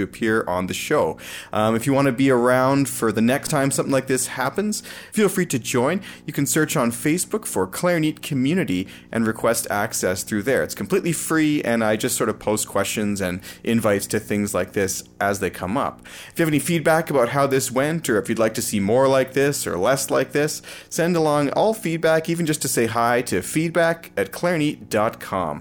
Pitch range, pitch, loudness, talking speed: 110-160 Hz, 135 Hz, -21 LUFS, 210 wpm